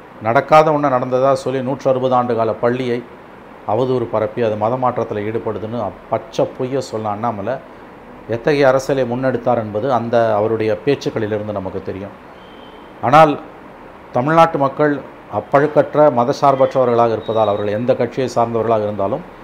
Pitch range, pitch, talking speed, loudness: 110-135 Hz, 125 Hz, 115 wpm, -17 LUFS